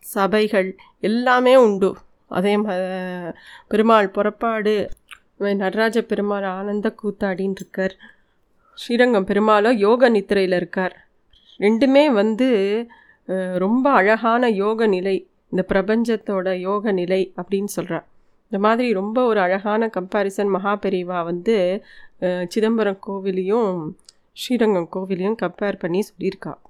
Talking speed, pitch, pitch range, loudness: 95 wpm, 200 Hz, 190-220 Hz, -20 LUFS